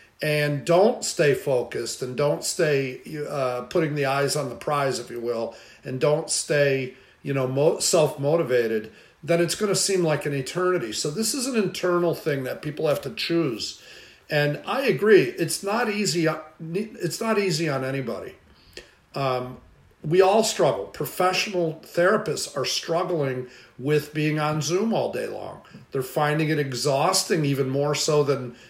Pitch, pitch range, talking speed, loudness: 150 Hz, 135-180 Hz, 160 wpm, -24 LUFS